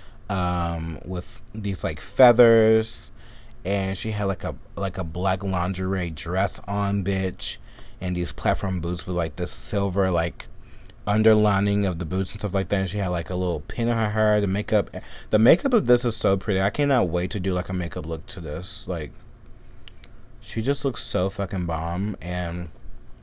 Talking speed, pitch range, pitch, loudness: 185 wpm, 90-105 Hz, 95 Hz, -24 LUFS